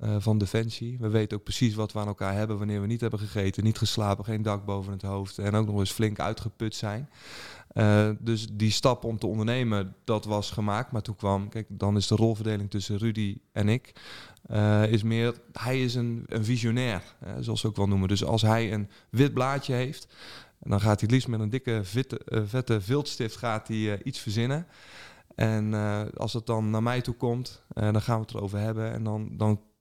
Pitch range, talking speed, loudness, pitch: 105-115 Hz, 215 wpm, -28 LUFS, 110 Hz